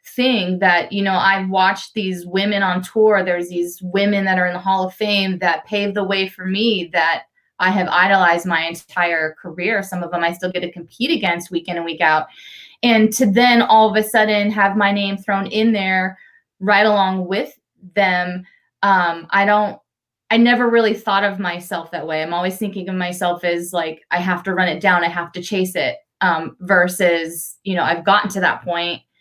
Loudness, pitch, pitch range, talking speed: -17 LUFS, 190 Hz, 175-205 Hz, 210 wpm